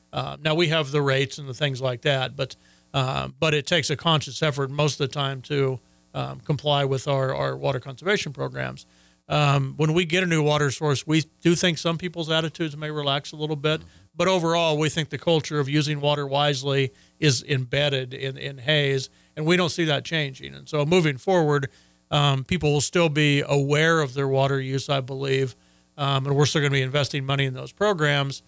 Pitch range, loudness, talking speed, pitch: 135-155 Hz, -23 LUFS, 210 wpm, 145 Hz